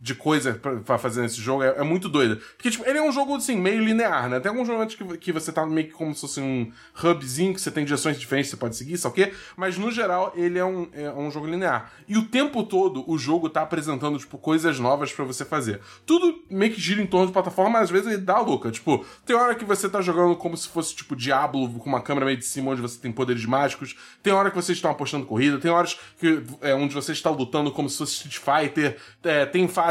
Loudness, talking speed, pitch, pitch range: -24 LUFS, 255 wpm, 160 Hz, 140-190 Hz